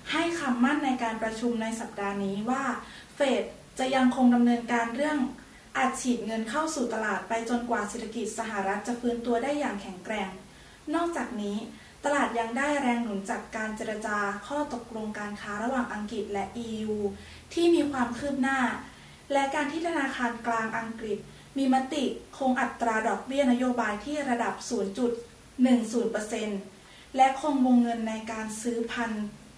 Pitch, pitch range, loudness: 235 Hz, 220-265 Hz, -29 LUFS